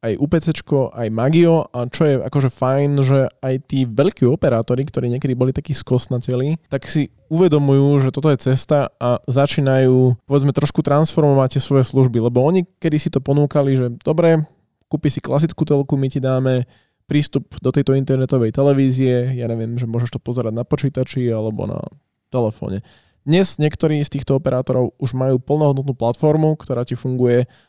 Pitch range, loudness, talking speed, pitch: 125-145 Hz, -18 LUFS, 165 wpm, 135 Hz